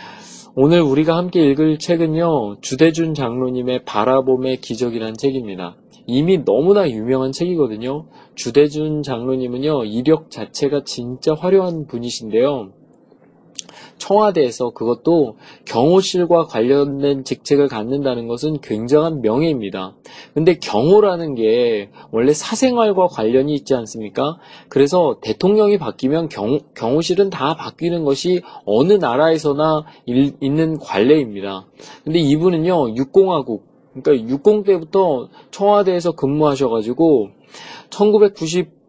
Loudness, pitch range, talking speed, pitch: -17 LUFS, 130-175 Hz, 285 characters per minute, 150 Hz